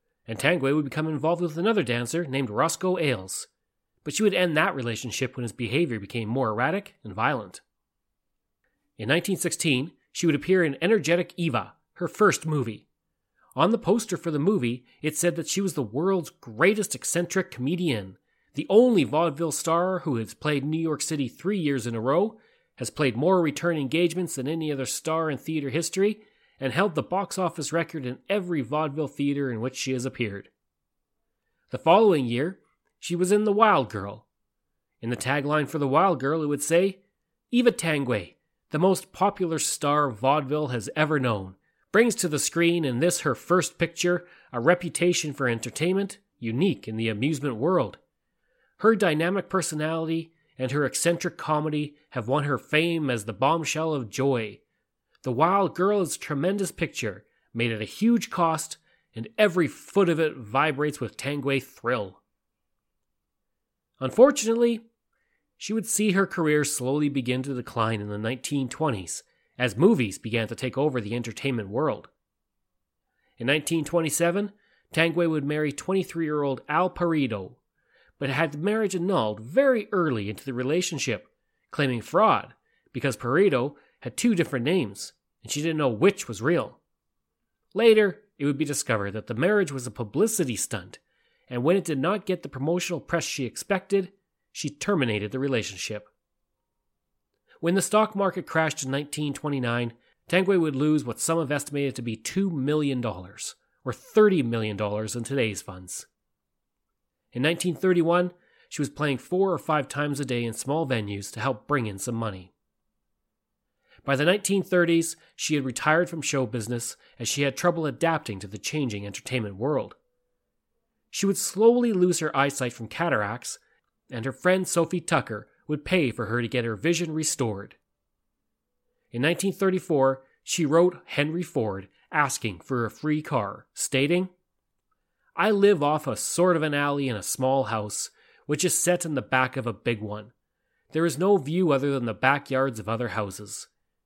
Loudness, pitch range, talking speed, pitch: -25 LUFS, 130-175 Hz, 160 wpm, 150 Hz